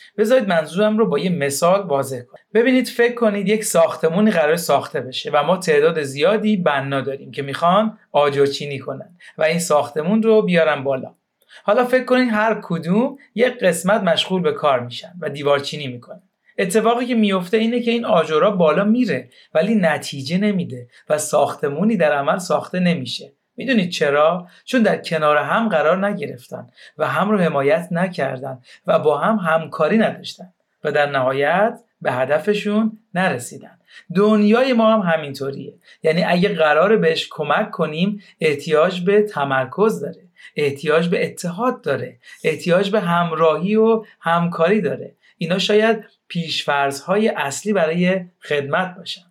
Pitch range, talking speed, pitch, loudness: 150-215 Hz, 145 wpm, 185 Hz, -18 LUFS